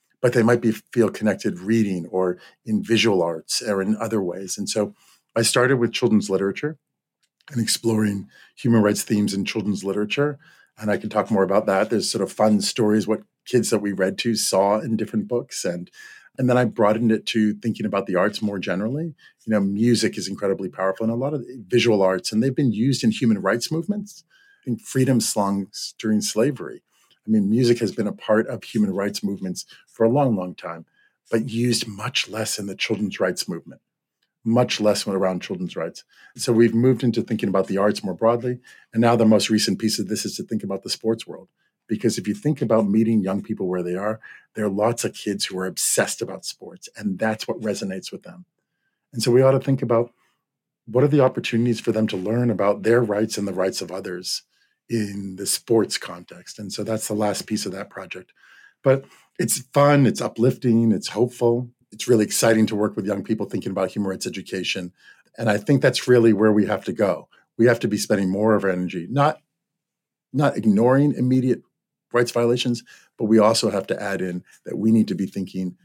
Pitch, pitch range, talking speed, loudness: 110 Hz, 100-120 Hz, 210 wpm, -22 LUFS